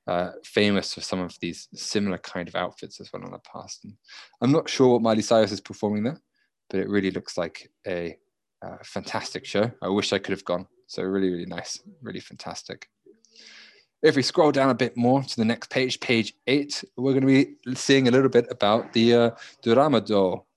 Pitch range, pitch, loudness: 100-130 Hz, 115 Hz, -24 LUFS